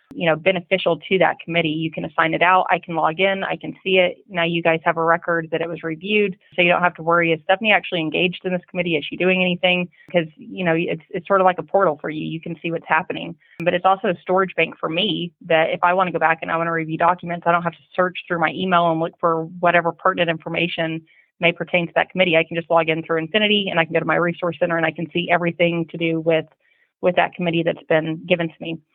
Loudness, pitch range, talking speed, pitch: -20 LUFS, 165-180 Hz, 280 wpm, 170 Hz